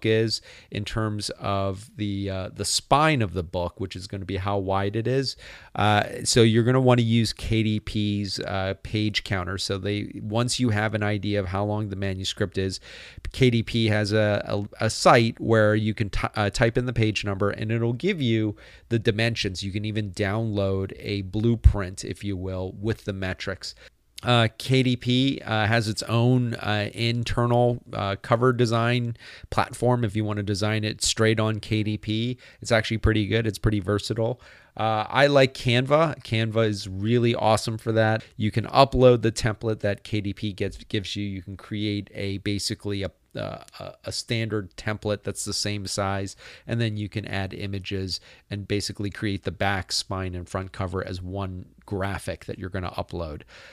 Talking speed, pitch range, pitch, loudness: 185 wpm, 100-115 Hz, 105 Hz, -25 LUFS